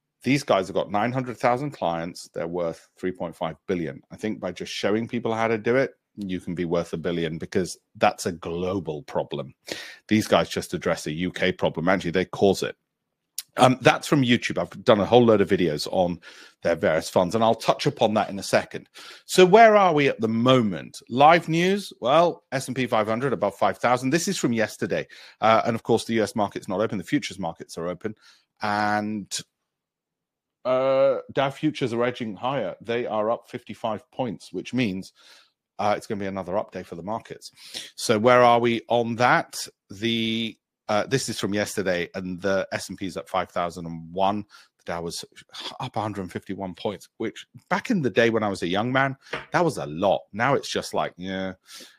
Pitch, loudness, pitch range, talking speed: 110 Hz, -24 LUFS, 95-125 Hz, 190 wpm